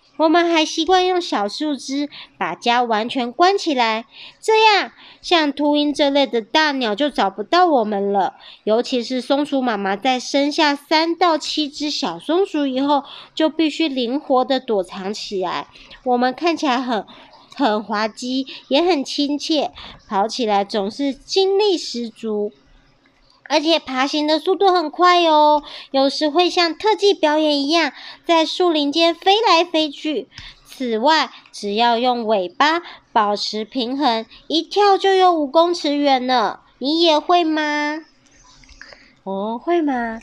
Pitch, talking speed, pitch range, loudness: 290 Hz, 205 characters per minute, 245-325 Hz, -18 LUFS